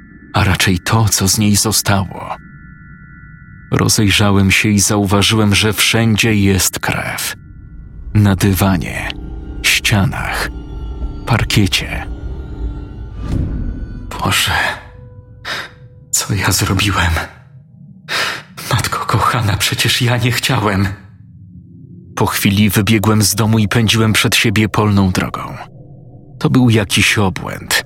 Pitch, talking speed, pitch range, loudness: 105 Hz, 95 wpm, 100-115 Hz, -14 LUFS